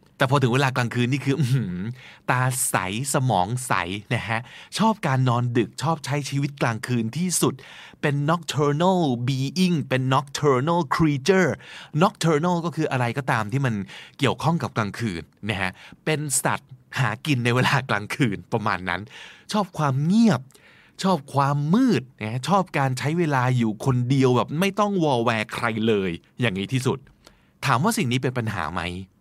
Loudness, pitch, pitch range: -23 LUFS, 135 Hz, 120-155 Hz